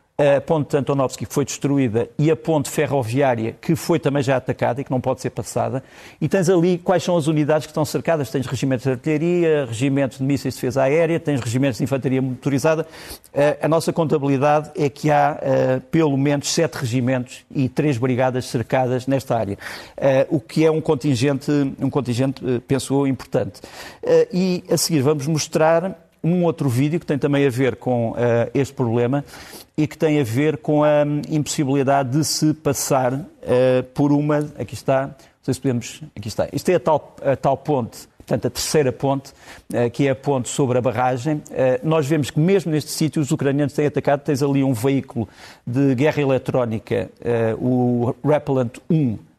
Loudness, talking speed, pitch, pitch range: -20 LUFS, 185 wpm, 140 Hz, 130-155 Hz